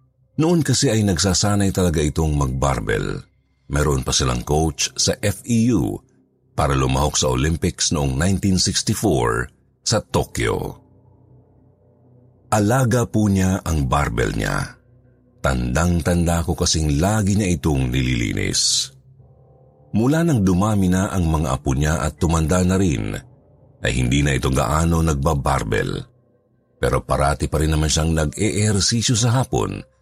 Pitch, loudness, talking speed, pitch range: 95 Hz, -19 LUFS, 120 wpm, 75-120 Hz